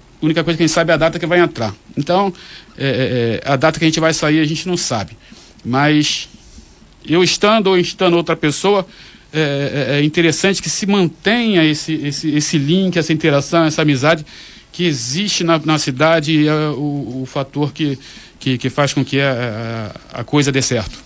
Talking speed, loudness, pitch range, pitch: 195 wpm, -15 LUFS, 140-170 Hz, 155 Hz